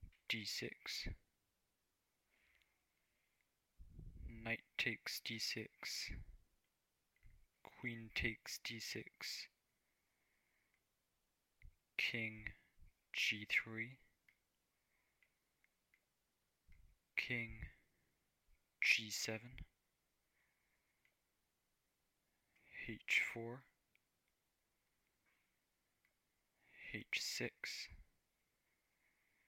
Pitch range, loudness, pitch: 95-115 Hz, -43 LUFS, 110 Hz